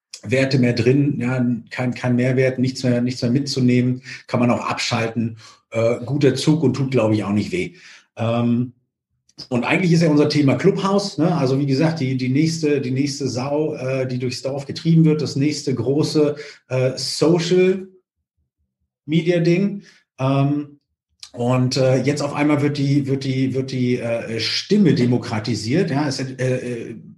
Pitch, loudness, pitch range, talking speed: 130 Hz, -19 LUFS, 125-150 Hz, 170 wpm